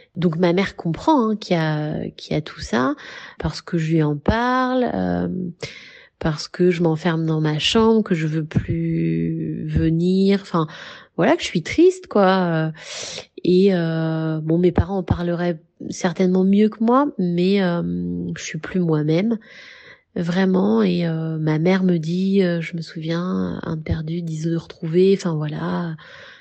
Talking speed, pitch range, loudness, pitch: 165 wpm, 160-190 Hz, -20 LUFS, 175 Hz